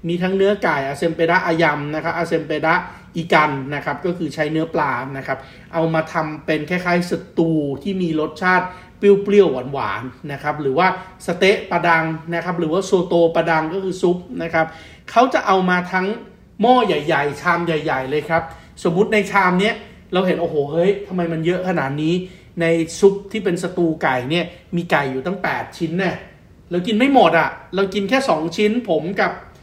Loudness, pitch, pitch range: -19 LUFS, 170 Hz, 160-185 Hz